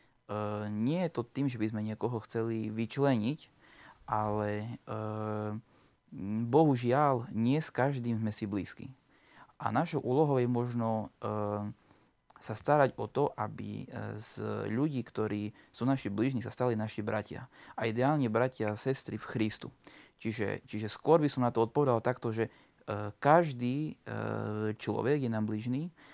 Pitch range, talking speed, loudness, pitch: 110-130 Hz, 150 wpm, -33 LUFS, 115 Hz